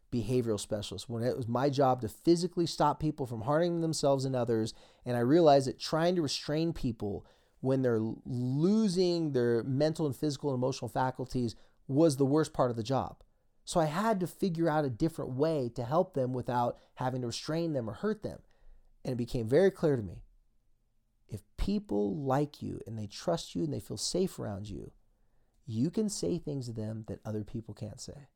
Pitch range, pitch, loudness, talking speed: 115-155 Hz, 130 Hz, -32 LUFS, 195 wpm